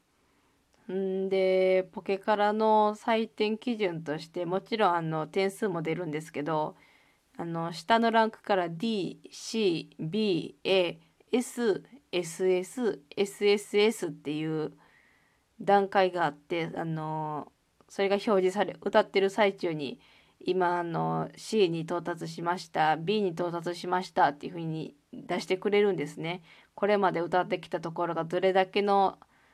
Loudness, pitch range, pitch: -29 LUFS, 170-205 Hz, 185 Hz